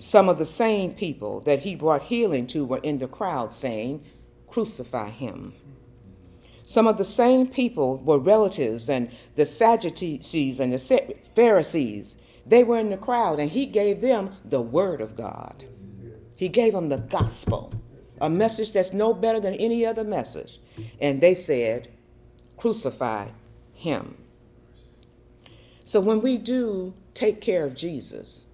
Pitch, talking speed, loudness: 155 Hz, 145 wpm, -23 LUFS